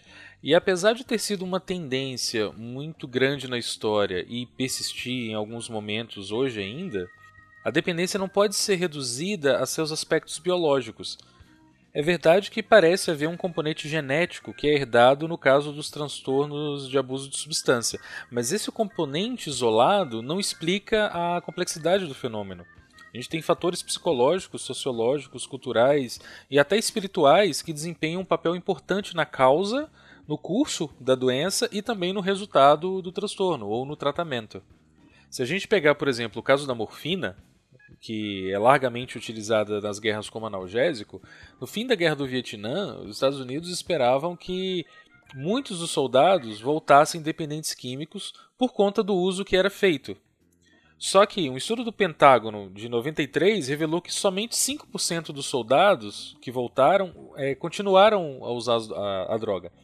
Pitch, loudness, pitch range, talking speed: 150 Hz, -25 LUFS, 120-185 Hz, 155 wpm